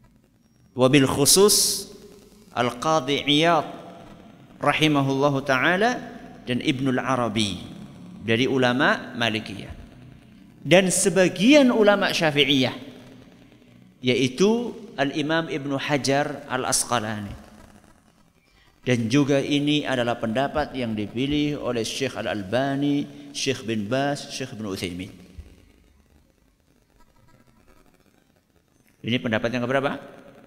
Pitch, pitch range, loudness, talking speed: 135 Hz, 115-150 Hz, -22 LUFS, 90 wpm